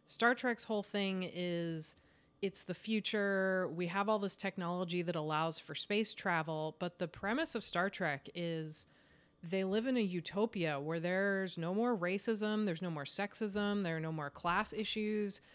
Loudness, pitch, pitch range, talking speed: -37 LUFS, 190 Hz, 170-210 Hz, 175 wpm